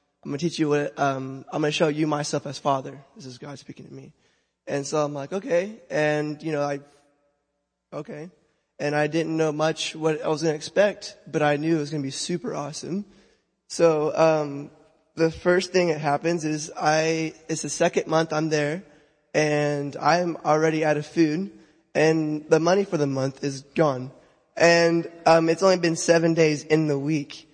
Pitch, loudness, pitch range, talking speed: 155 Hz, -24 LUFS, 145-165 Hz, 200 wpm